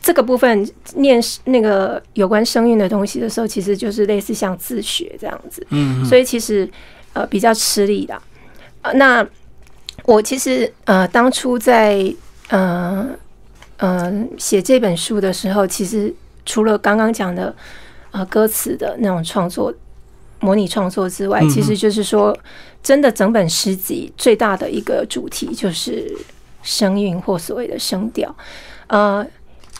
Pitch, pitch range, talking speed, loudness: 210 Hz, 195-245 Hz, 220 characters per minute, -16 LUFS